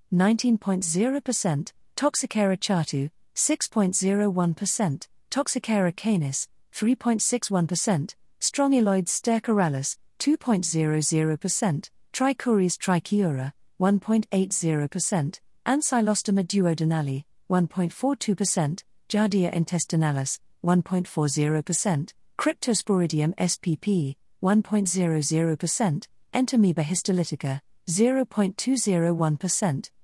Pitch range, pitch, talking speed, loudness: 165-215 Hz, 185 Hz, 50 wpm, -25 LUFS